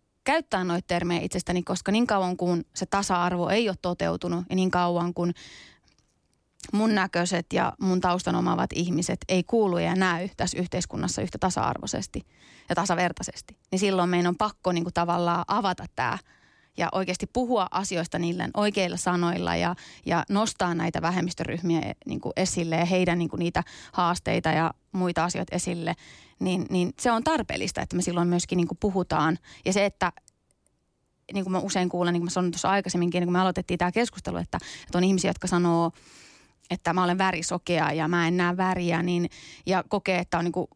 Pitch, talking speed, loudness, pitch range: 180 Hz, 175 wpm, -26 LUFS, 170-185 Hz